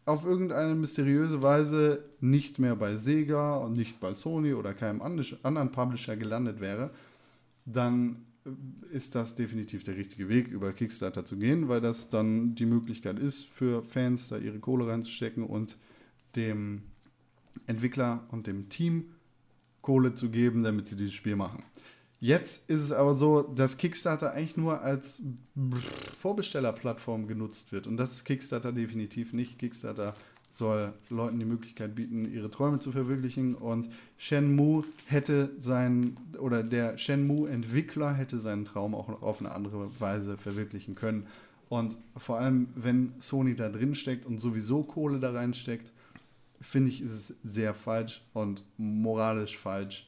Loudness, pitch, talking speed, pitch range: -31 LUFS, 120 Hz, 150 wpm, 110-140 Hz